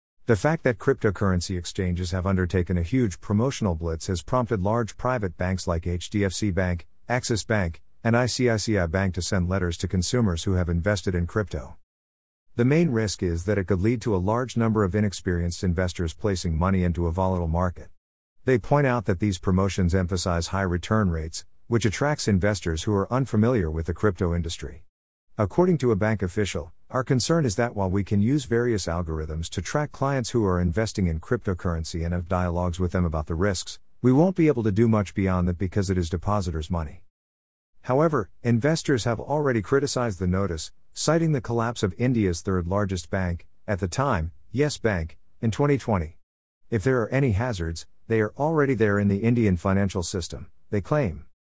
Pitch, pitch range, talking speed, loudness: 100 Hz, 90-115 Hz, 185 wpm, -25 LUFS